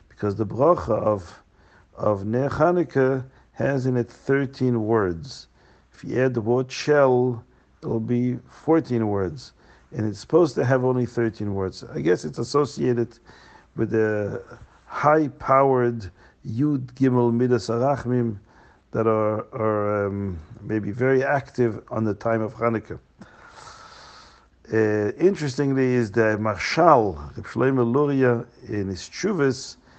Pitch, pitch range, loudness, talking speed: 120 Hz, 110-130 Hz, -23 LUFS, 125 wpm